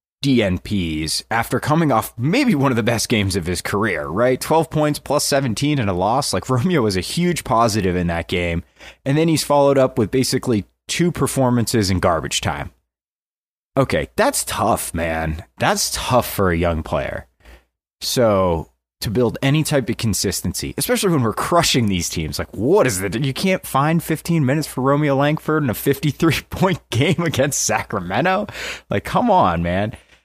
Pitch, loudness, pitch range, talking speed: 125 Hz, -19 LUFS, 95-145 Hz, 175 wpm